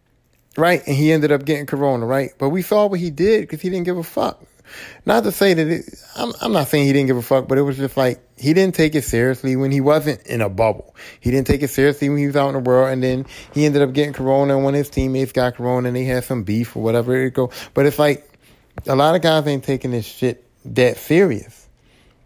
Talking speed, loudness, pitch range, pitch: 260 wpm, -18 LUFS, 130-150 Hz, 135 Hz